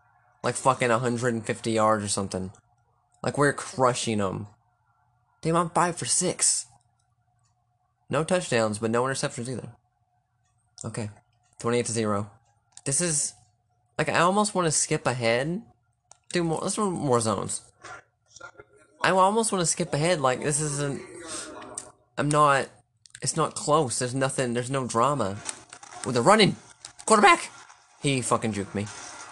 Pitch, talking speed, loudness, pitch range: 120 Hz, 135 wpm, -25 LUFS, 115-145 Hz